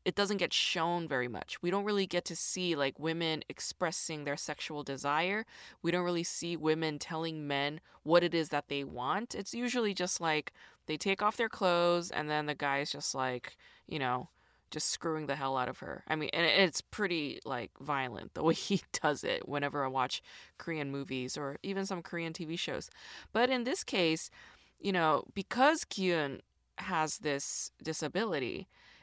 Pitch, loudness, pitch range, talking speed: 165 Hz, -33 LUFS, 145-185 Hz, 185 wpm